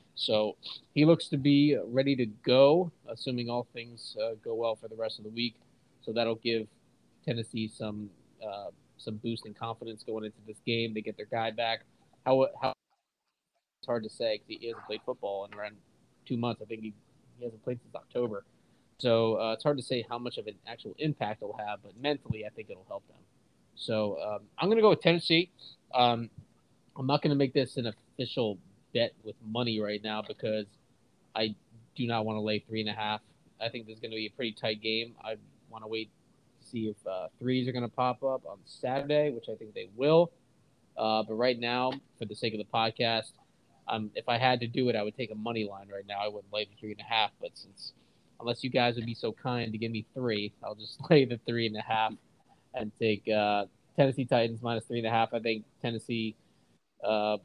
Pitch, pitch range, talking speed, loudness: 115 Hz, 110-125 Hz, 225 wpm, -31 LUFS